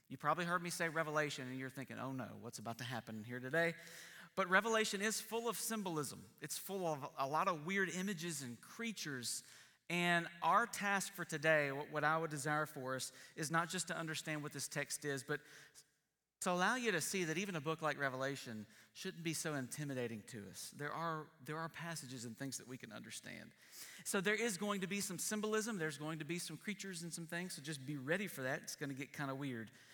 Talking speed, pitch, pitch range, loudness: 225 wpm, 155 Hz, 135-180 Hz, -41 LUFS